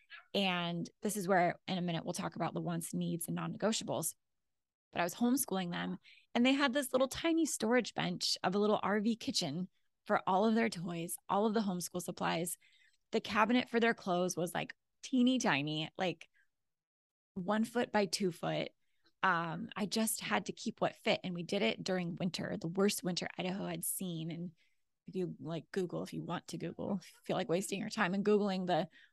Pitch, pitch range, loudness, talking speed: 190 Hz, 175-220 Hz, -35 LUFS, 200 wpm